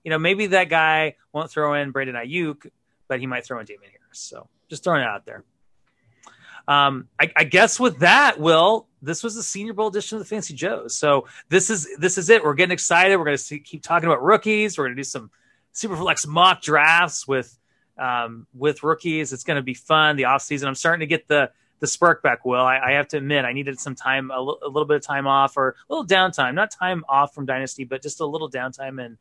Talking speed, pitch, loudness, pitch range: 240 wpm, 150 Hz, -20 LUFS, 135-175 Hz